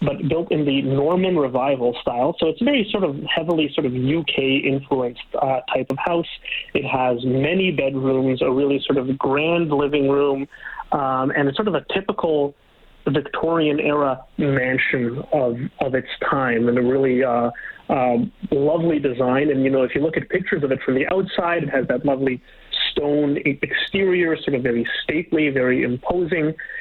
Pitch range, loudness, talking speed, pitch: 130-155 Hz, -20 LUFS, 175 wpm, 140 Hz